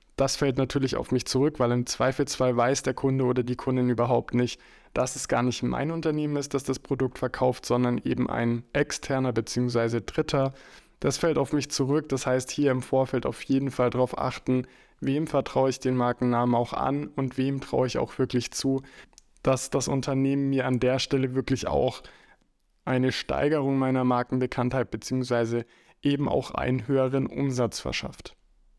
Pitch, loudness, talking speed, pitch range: 130 Hz, -27 LUFS, 175 wpm, 125-135 Hz